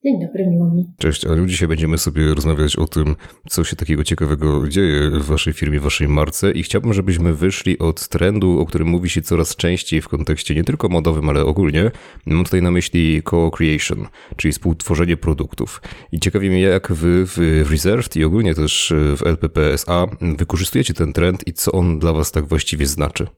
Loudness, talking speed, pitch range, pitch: -17 LUFS, 180 wpm, 80-90 Hz, 85 Hz